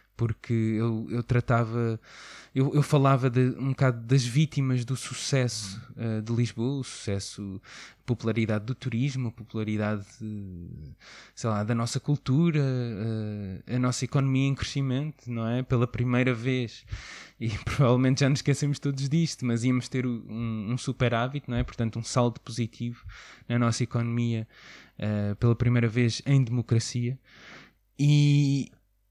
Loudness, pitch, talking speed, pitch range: -27 LUFS, 120 Hz, 145 wpm, 110-130 Hz